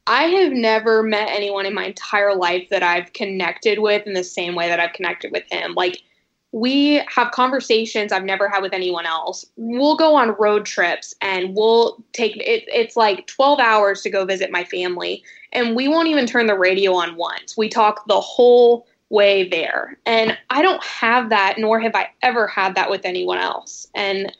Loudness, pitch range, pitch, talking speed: -18 LUFS, 190-240 Hz, 215 Hz, 195 wpm